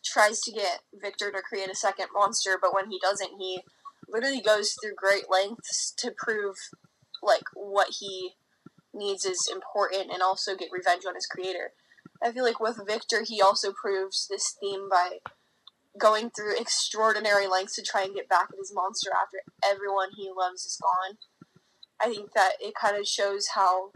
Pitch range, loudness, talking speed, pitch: 190-220 Hz, -27 LUFS, 180 wpm, 200 Hz